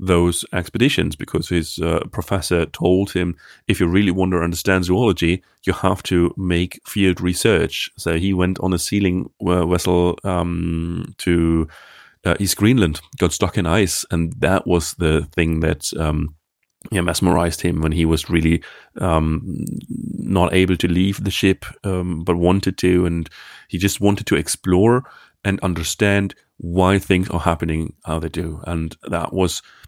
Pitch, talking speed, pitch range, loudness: 90 Hz, 160 wpm, 85-95 Hz, -19 LUFS